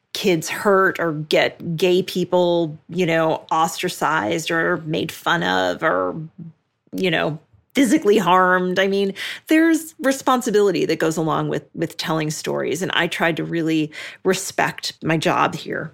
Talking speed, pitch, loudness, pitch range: 145 wpm, 170 Hz, -20 LUFS, 160-190 Hz